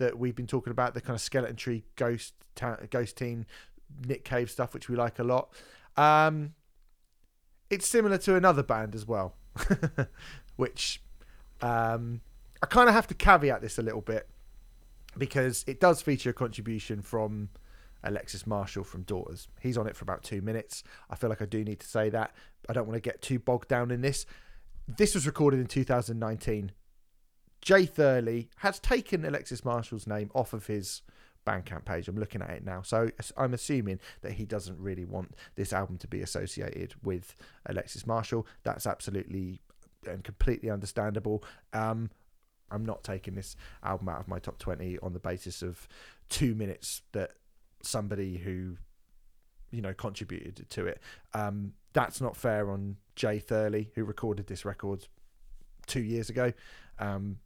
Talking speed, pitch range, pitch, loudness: 170 wpm, 100-125 Hz, 110 Hz, -31 LUFS